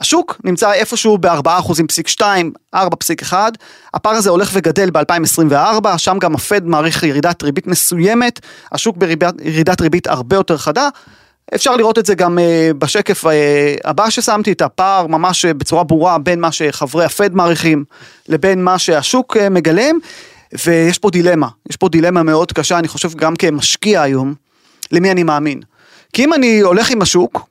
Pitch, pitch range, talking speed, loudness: 175 Hz, 160-205 Hz, 155 wpm, -13 LUFS